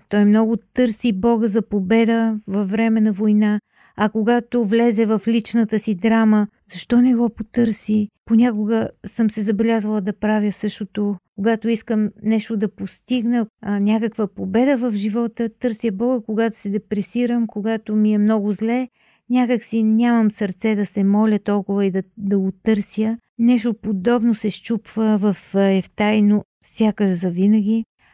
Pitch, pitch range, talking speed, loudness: 220 Hz, 210-230 Hz, 145 wpm, -19 LUFS